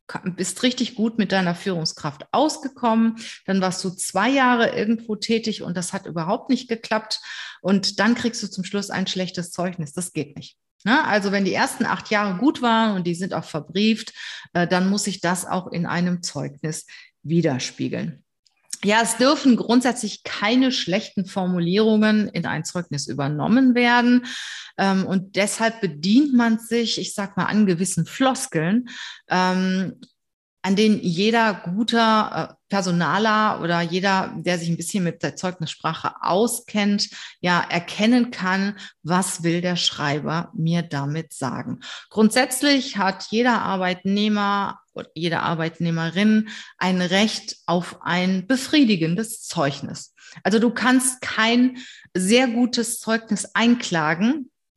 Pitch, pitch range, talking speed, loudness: 195 Hz, 175-225 Hz, 135 wpm, -21 LUFS